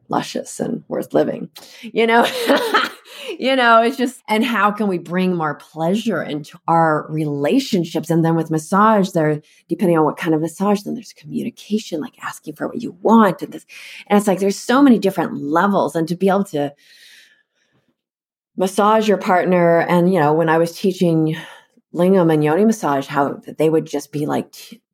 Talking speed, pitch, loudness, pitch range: 185 wpm, 180 Hz, -17 LUFS, 160-215 Hz